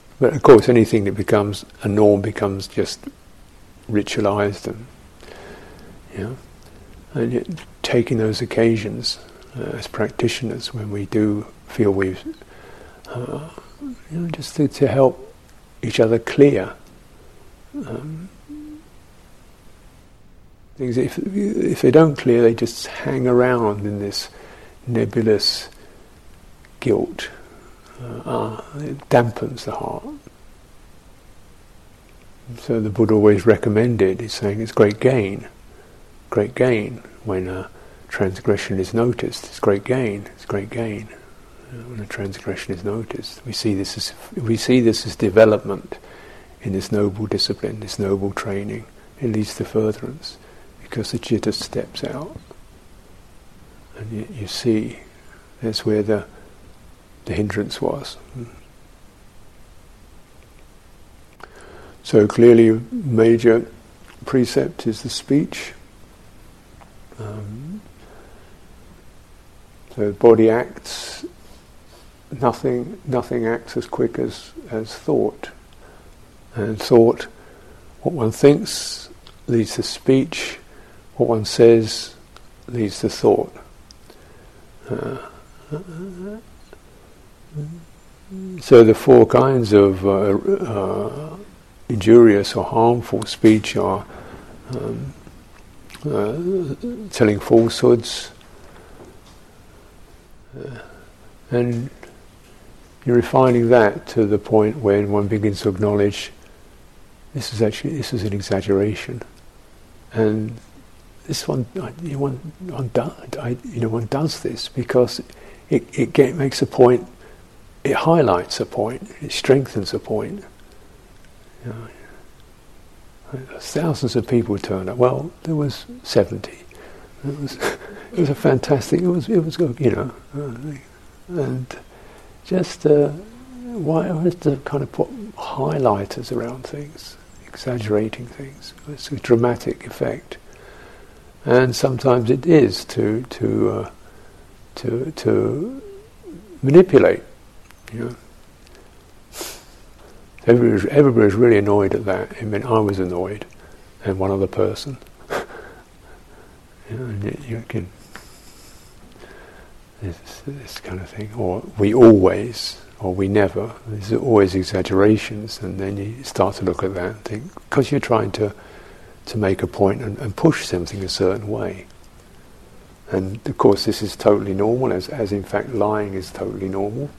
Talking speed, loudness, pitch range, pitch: 120 wpm, -19 LUFS, 100-130 Hz, 115 Hz